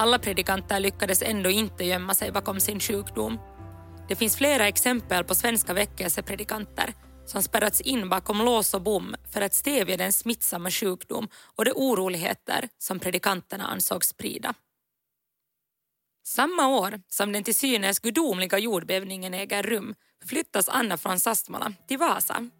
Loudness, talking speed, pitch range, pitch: -25 LUFS, 140 wpm, 185-230 Hz, 200 Hz